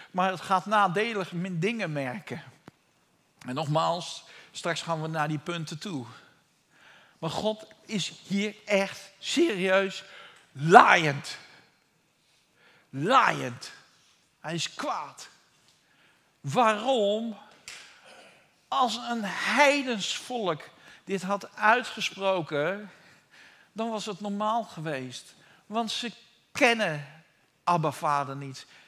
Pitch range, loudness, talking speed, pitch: 165-215 Hz, -27 LUFS, 90 wpm, 195 Hz